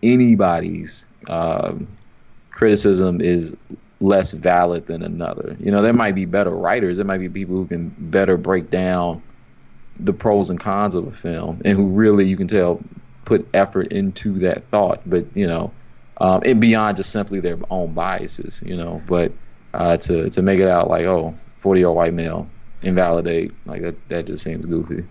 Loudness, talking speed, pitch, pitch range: -19 LUFS, 180 wpm, 95 Hz, 85-100 Hz